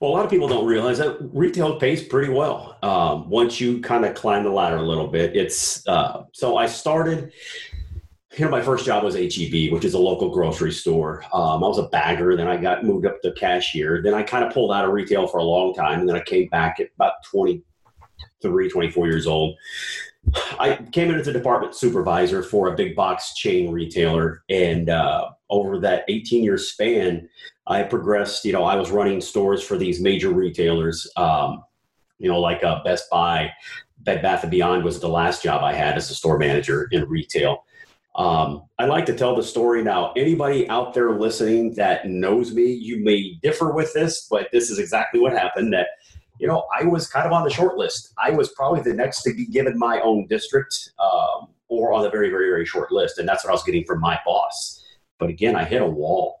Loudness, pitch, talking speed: -21 LUFS, 115 Hz, 215 wpm